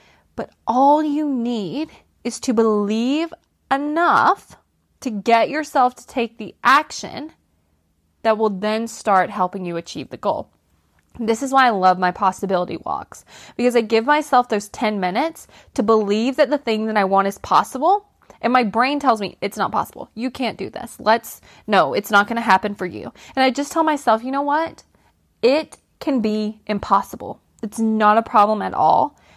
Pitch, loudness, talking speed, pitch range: 230 Hz, -19 LUFS, 180 wpm, 210-275 Hz